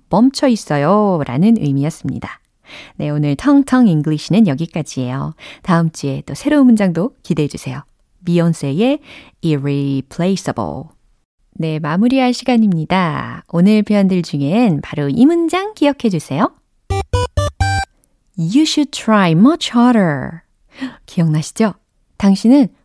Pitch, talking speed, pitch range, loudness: 175 Hz, 320 characters per minute, 145-240 Hz, -15 LUFS